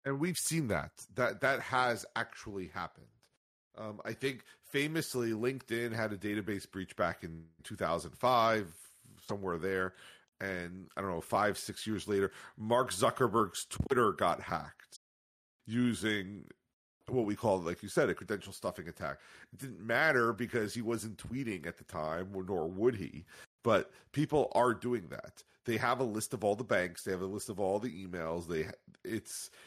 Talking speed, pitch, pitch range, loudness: 170 wpm, 110 Hz, 95-120 Hz, -35 LUFS